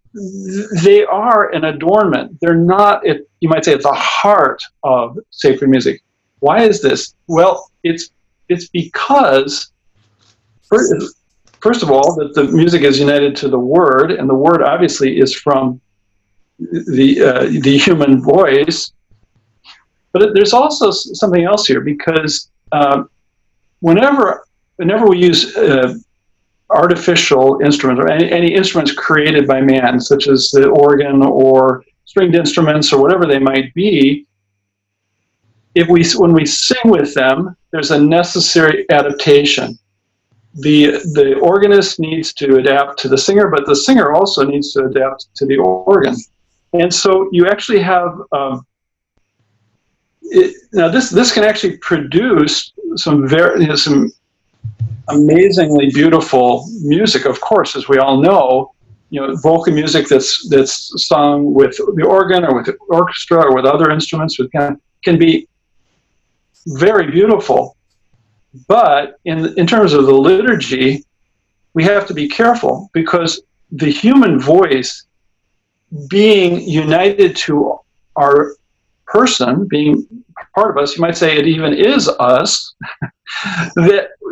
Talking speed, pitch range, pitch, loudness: 135 wpm, 130-180 Hz, 150 Hz, -12 LUFS